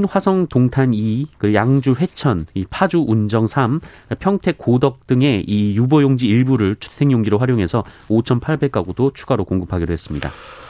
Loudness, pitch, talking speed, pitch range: -17 LUFS, 120 Hz, 280 characters per minute, 105-140 Hz